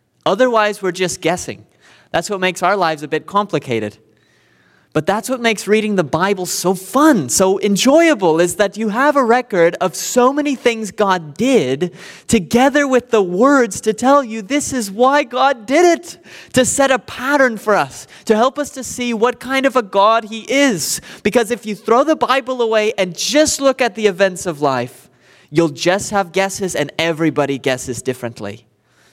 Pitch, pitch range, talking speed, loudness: 210 Hz, 175-255 Hz, 185 wpm, -16 LUFS